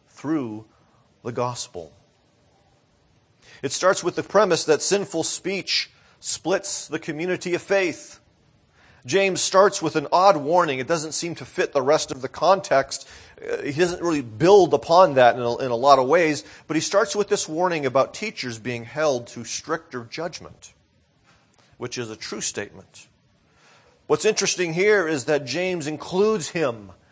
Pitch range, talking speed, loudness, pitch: 130-185 Hz, 155 wpm, -22 LUFS, 155 Hz